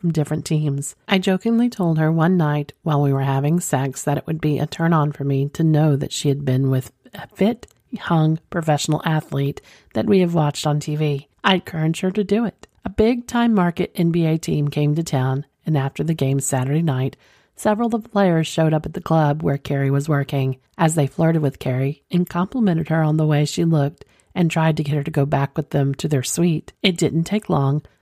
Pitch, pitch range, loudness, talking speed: 155 Hz, 140-170 Hz, -20 LUFS, 225 wpm